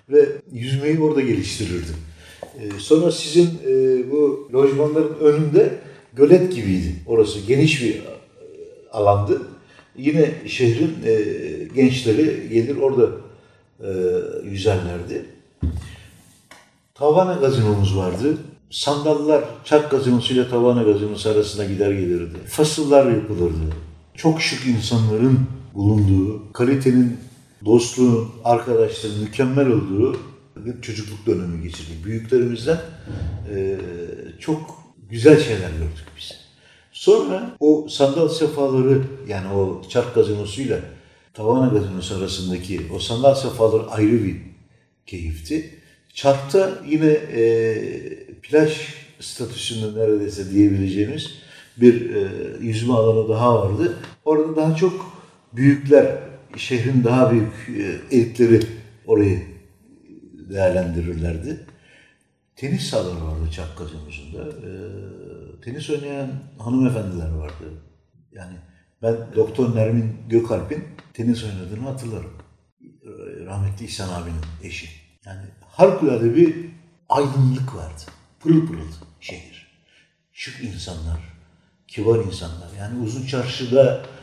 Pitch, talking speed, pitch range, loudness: 115 Hz, 95 wpm, 95-145 Hz, -19 LUFS